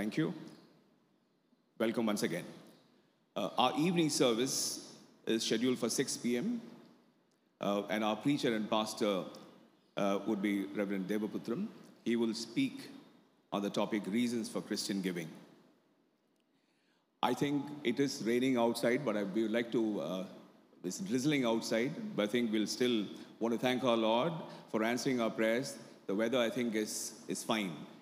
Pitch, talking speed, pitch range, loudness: 115 Hz, 155 wpm, 105-130 Hz, -35 LUFS